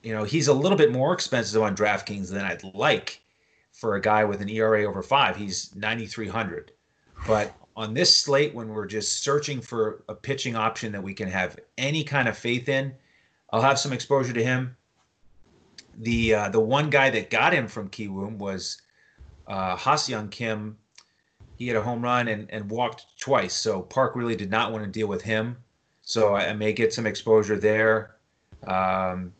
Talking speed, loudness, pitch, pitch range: 190 wpm, -25 LUFS, 110 Hz, 105-120 Hz